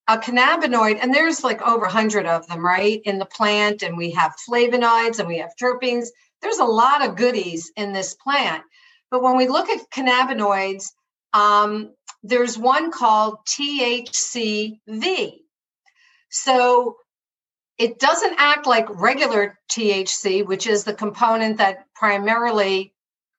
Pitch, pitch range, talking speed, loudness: 230 Hz, 205-255 Hz, 140 wpm, -19 LUFS